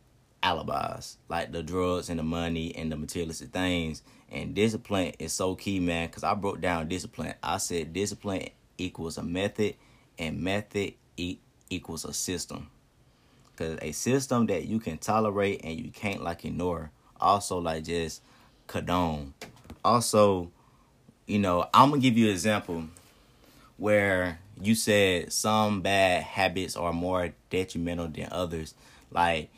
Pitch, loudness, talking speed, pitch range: 90 Hz, -29 LUFS, 140 wpm, 85-105 Hz